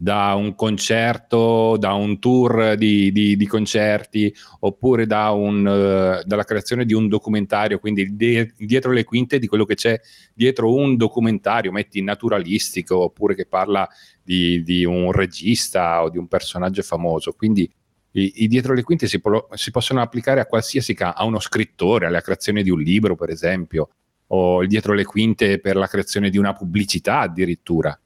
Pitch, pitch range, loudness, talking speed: 105 Hz, 95-115 Hz, -19 LUFS, 170 wpm